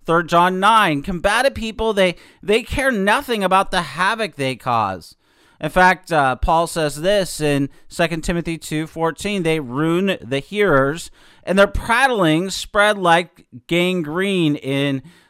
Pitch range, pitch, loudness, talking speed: 155-195 Hz, 175 Hz, -18 LUFS, 140 wpm